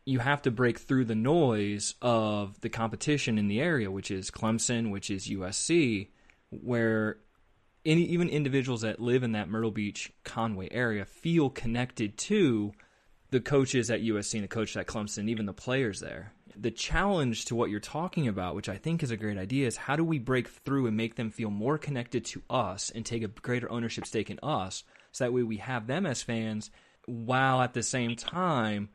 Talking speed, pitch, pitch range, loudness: 195 wpm, 115 Hz, 105-130 Hz, -30 LUFS